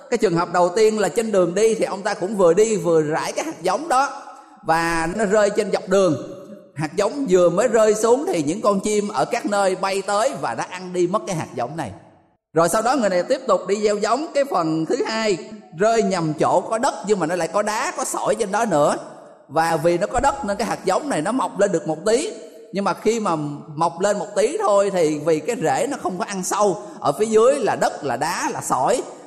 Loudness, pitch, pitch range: -20 LUFS, 200 Hz, 170-220 Hz